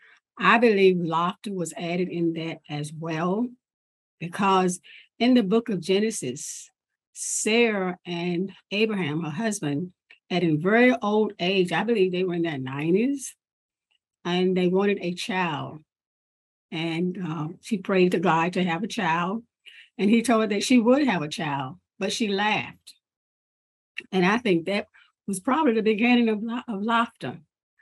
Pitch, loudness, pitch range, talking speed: 185 Hz, -24 LUFS, 170-220 Hz, 155 wpm